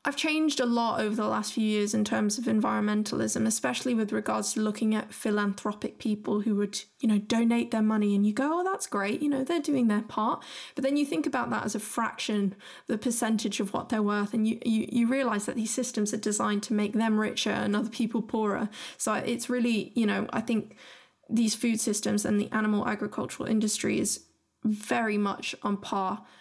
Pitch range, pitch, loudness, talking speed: 210-240 Hz, 220 Hz, -28 LUFS, 210 wpm